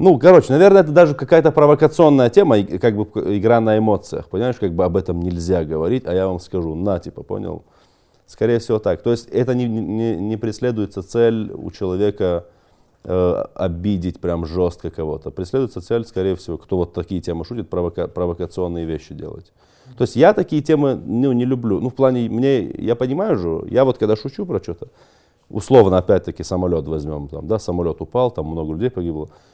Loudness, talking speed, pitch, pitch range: -18 LUFS, 185 wpm, 105 Hz, 90-125 Hz